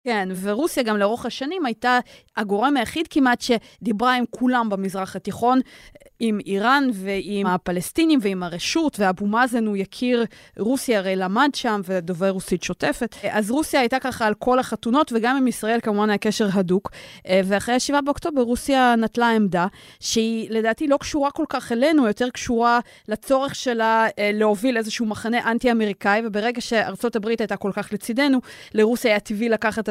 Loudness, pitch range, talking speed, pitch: -21 LUFS, 205-250 Hz, 155 wpm, 225 Hz